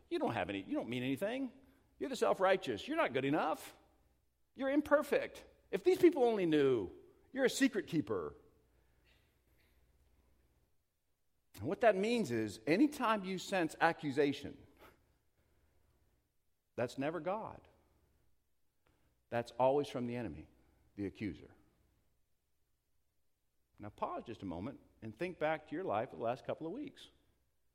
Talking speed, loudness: 135 wpm, -36 LUFS